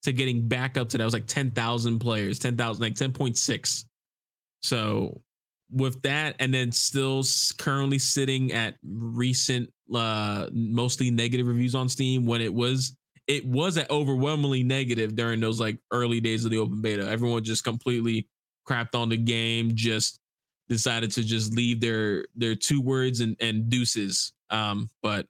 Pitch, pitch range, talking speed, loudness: 120 Hz, 115-130 Hz, 160 wpm, -26 LUFS